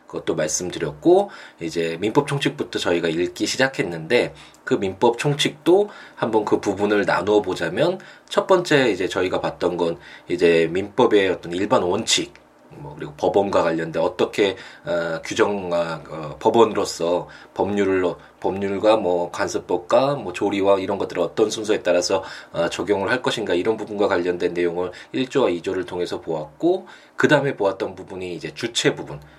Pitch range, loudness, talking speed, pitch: 85-110 Hz, -21 LUFS, 330 characters per minute, 95 Hz